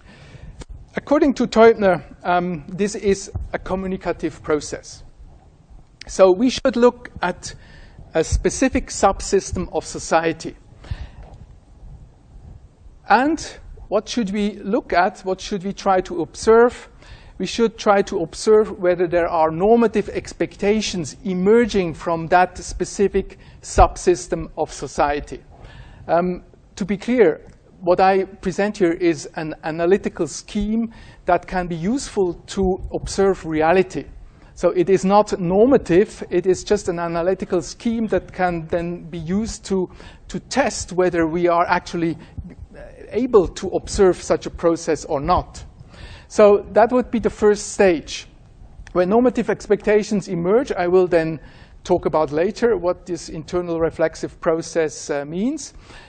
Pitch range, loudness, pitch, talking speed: 170-210 Hz, -20 LUFS, 185 Hz, 130 wpm